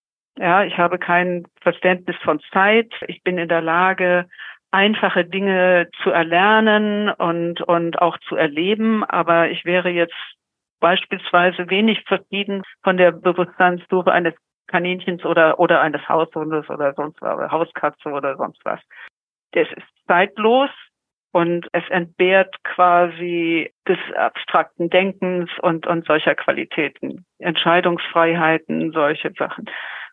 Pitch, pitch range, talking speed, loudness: 175 Hz, 170-185 Hz, 120 wpm, -18 LUFS